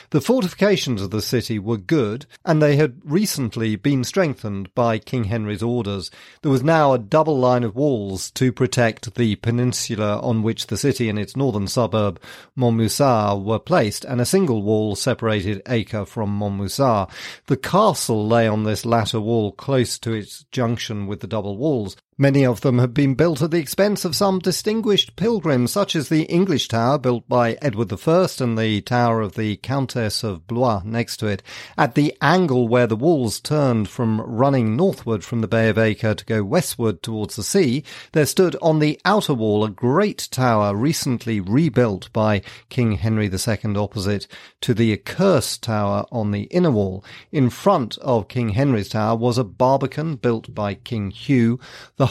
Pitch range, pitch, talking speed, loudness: 110-140 Hz, 120 Hz, 180 wpm, -20 LUFS